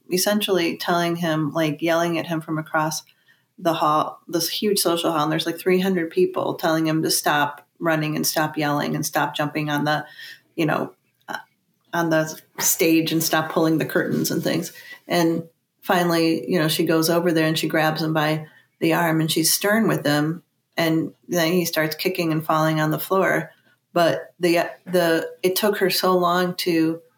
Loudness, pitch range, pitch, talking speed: -21 LUFS, 155-175 Hz, 165 Hz, 190 wpm